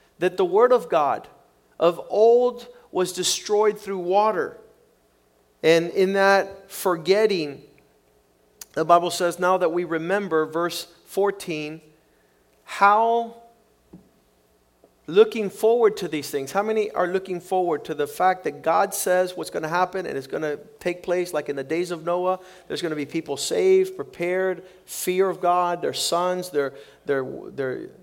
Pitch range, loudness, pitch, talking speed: 160-200 Hz, -23 LUFS, 180 Hz, 155 wpm